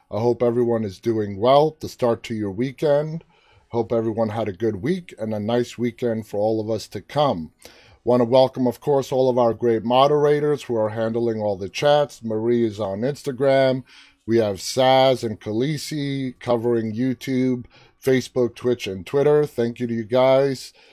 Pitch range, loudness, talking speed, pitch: 110-135 Hz, -21 LUFS, 180 wpm, 120 Hz